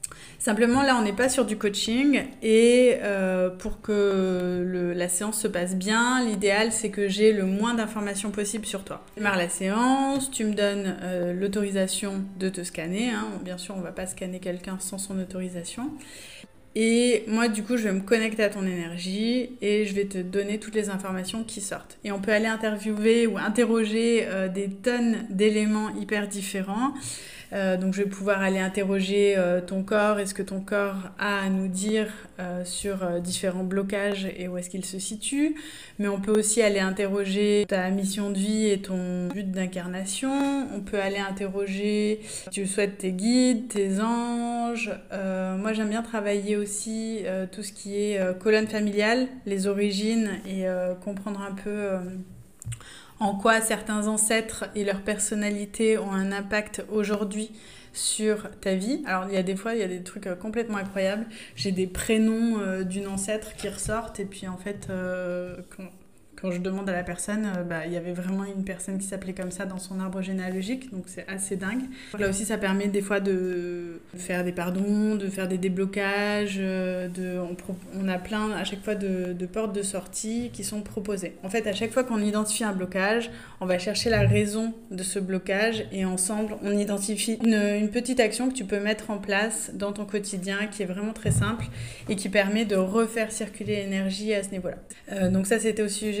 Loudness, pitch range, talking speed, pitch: -27 LUFS, 190-215 Hz, 195 wpm, 200 Hz